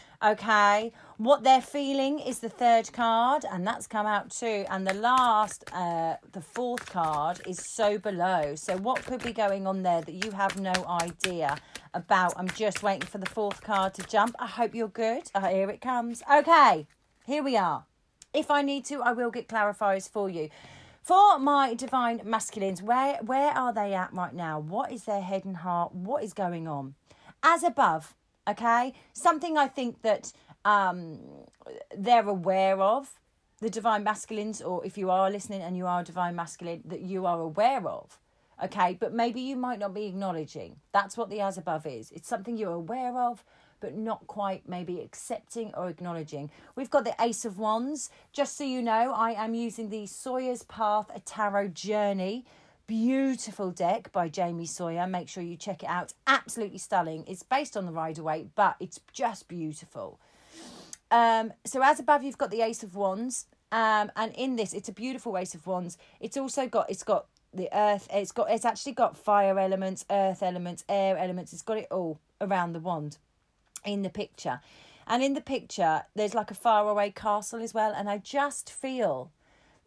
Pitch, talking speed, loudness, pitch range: 210 Hz, 190 wpm, -28 LUFS, 185-240 Hz